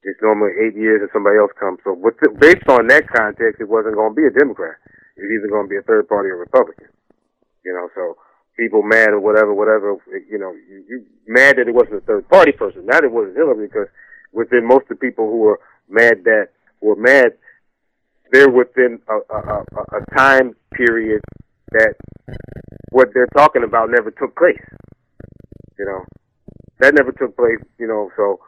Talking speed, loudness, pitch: 195 wpm, -14 LUFS, 135 Hz